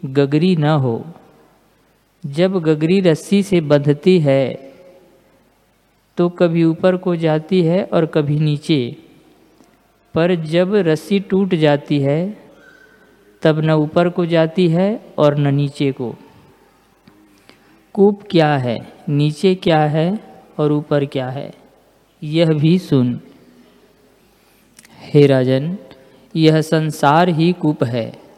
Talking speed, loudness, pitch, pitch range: 115 wpm, -16 LUFS, 155 Hz, 145-180 Hz